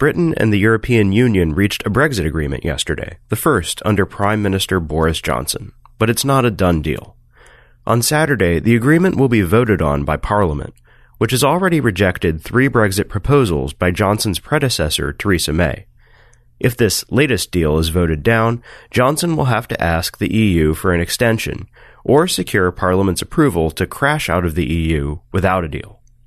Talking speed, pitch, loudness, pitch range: 170 wpm, 100 Hz, -16 LUFS, 85-120 Hz